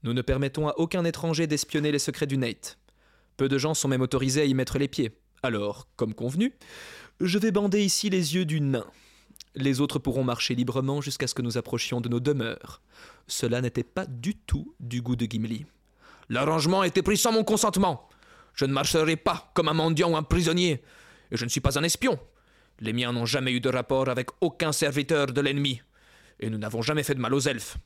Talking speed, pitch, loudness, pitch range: 215 wpm, 140 Hz, -27 LUFS, 125-160 Hz